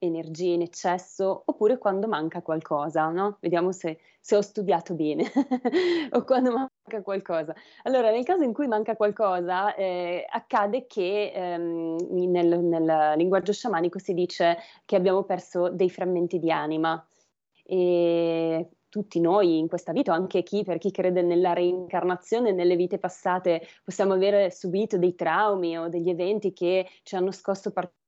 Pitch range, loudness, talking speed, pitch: 170-200 Hz, -26 LUFS, 150 wpm, 180 Hz